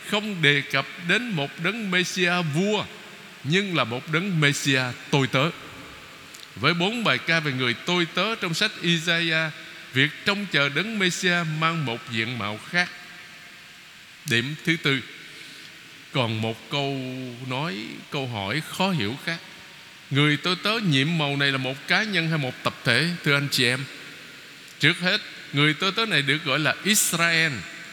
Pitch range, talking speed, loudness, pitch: 140-180 Hz, 165 wpm, -23 LUFS, 160 Hz